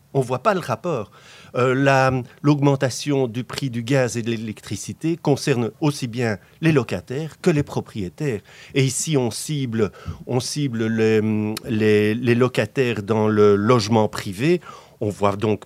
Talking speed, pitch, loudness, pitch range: 155 wpm, 125 Hz, -21 LUFS, 110-140 Hz